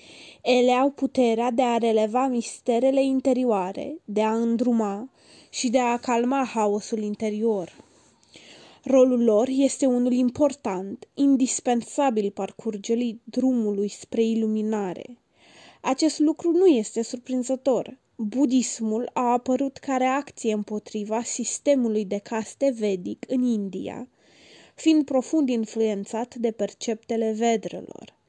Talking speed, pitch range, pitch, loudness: 105 wpm, 220-260 Hz, 240 Hz, -24 LUFS